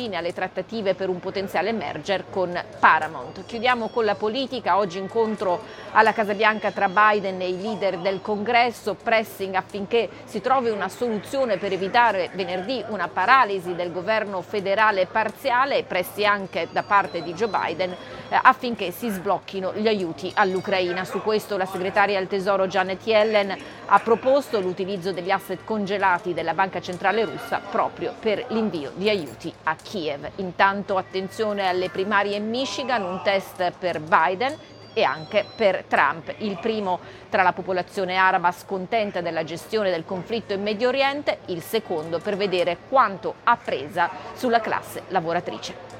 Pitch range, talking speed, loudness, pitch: 185-220 Hz, 150 wpm, -23 LUFS, 195 Hz